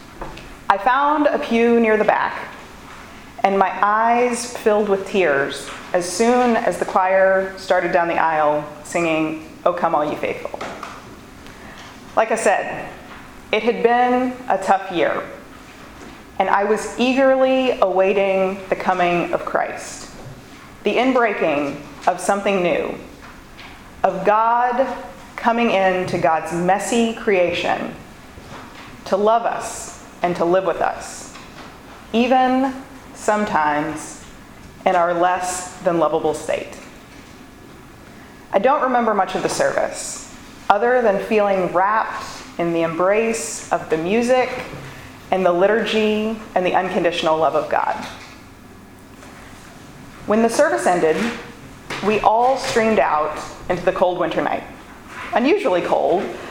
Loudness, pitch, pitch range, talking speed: -19 LUFS, 195 Hz, 180-235 Hz, 120 wpm